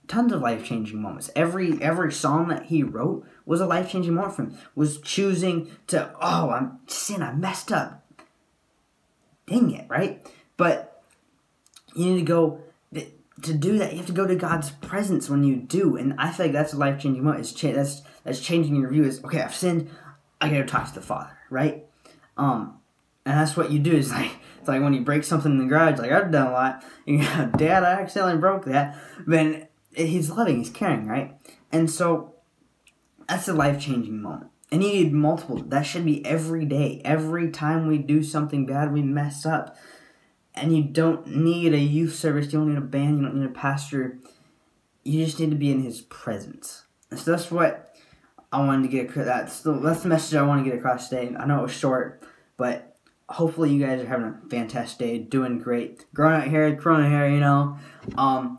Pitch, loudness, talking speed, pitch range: 150 Hz, -24 LUFS, 210 wpm, 140-165 Hz